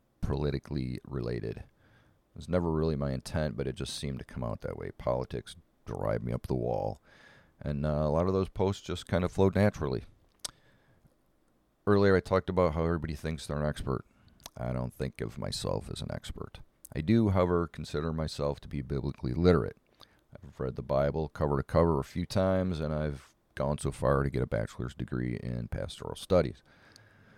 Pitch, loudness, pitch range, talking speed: 75 Hz, -32 LUFS, 65-90 Hz, 185 wpm